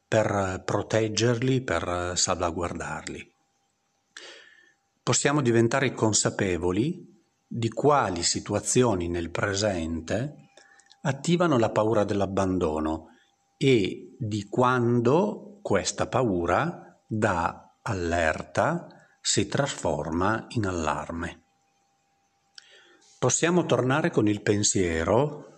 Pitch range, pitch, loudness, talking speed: 90-125 Hz, 110 Hz, -26 LUFS, 75 wpm